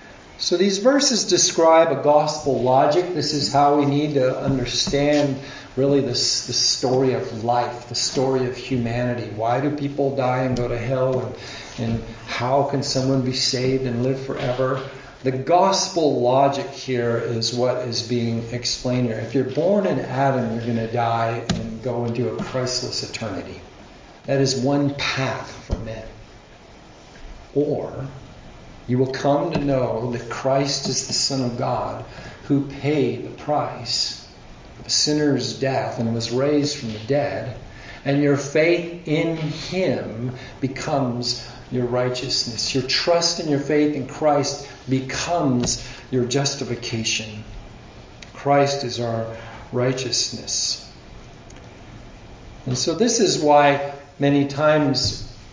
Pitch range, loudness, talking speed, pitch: 120-140 Hz, -21 LUFS, 140 wpm, 130 Hz